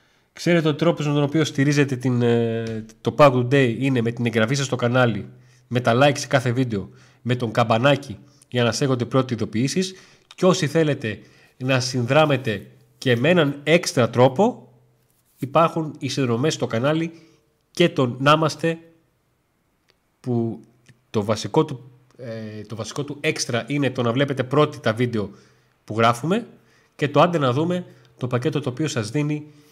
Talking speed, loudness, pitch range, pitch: 160 wpm, -21 LUFS, 120-150 Hz, 135 Hz